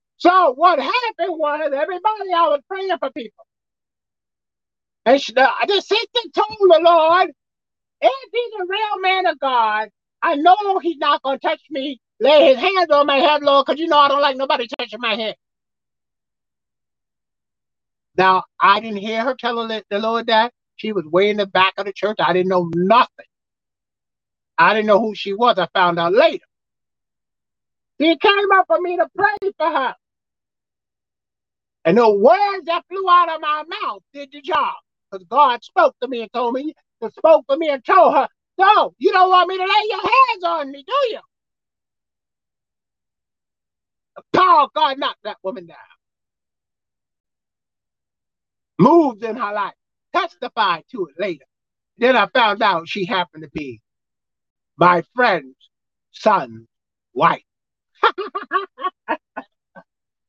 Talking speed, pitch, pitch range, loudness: 155 wpm, 290 Hz, 220-360 Hz, -17 LUFS